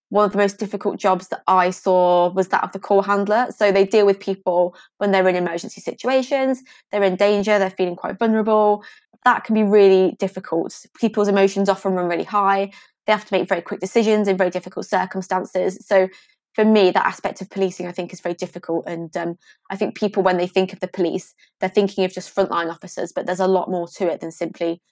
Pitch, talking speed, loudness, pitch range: 195 Hz, 220 wpm, -20 LUFS, 185-210 Hz